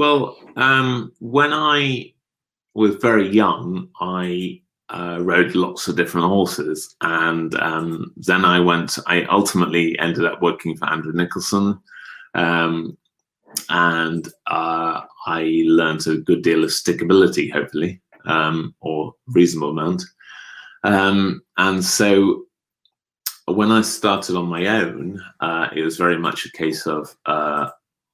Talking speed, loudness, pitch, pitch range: 130 wpm, -19 LUFS, 90 Hz, 80-110 Hz